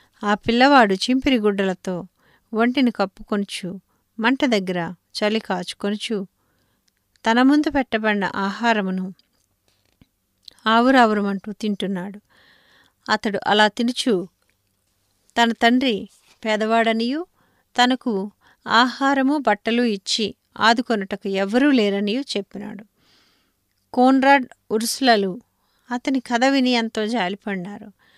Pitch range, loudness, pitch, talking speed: 195-245 Hz, -20 LUFS, 215 Hz, 80 wpm